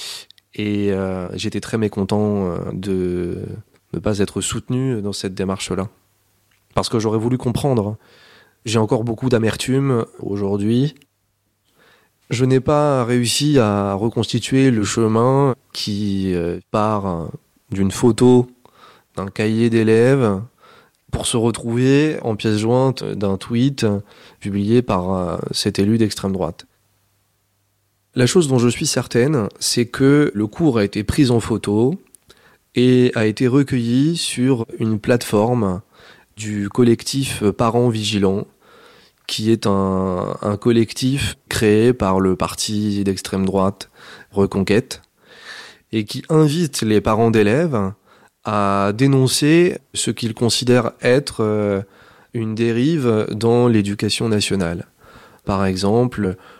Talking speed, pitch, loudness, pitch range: 115 wpm, 110 Hz, -18 LUFS, 100-125 Hz